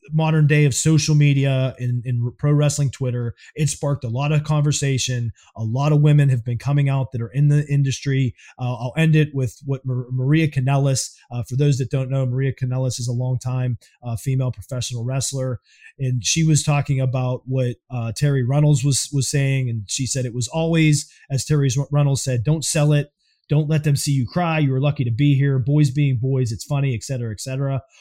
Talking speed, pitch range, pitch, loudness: 210 wpm, 125-145 Hz, 135 Hz, -20 LUFS